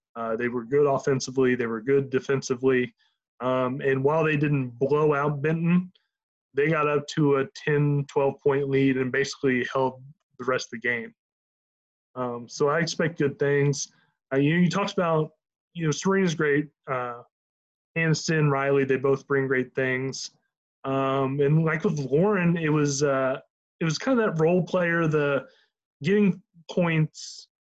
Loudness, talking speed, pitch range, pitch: -25 LUFS, 165 wpm, 135-160 Hz, 145 Hz